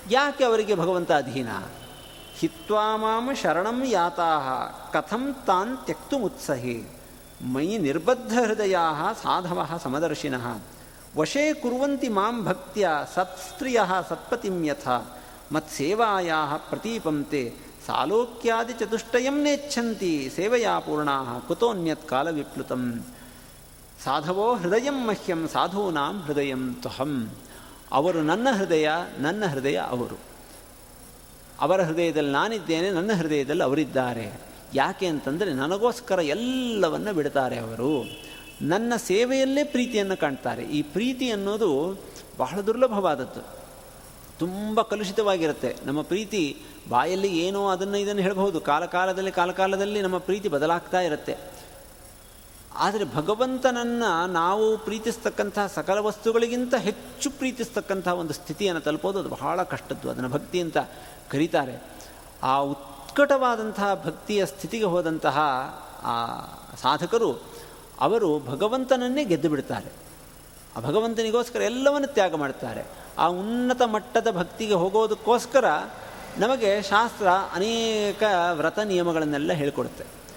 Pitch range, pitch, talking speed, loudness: 155-225 Hz, 190 Hz, 90 wpm, -25 LUFS